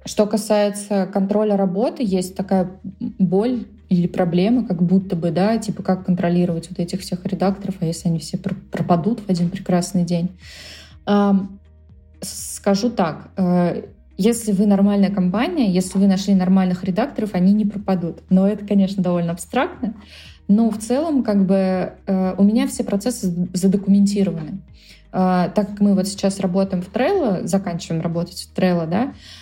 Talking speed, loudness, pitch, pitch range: 145 wpm, -19 LUFS, 195 Hz, 180-205 Hz